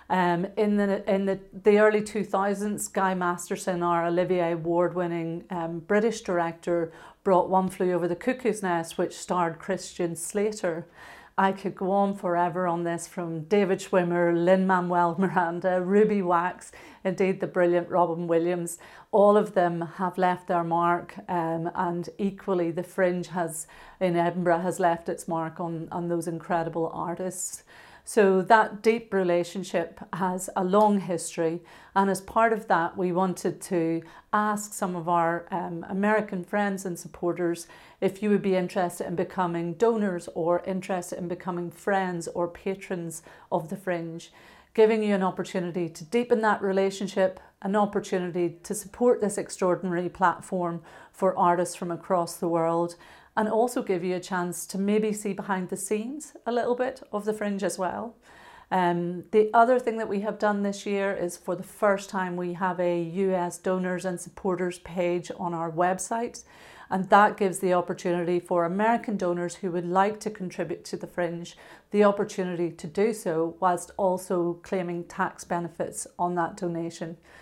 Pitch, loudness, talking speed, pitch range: 185 Hz, -27 LUFS, 165 wpm, 175-200 Hz